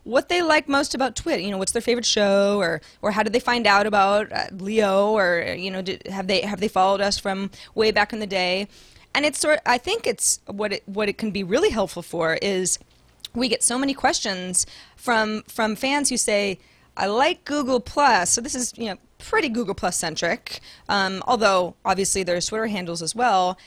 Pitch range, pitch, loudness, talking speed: 190-245 Hz, 210 Hz, -22 LUFS, 215 wpm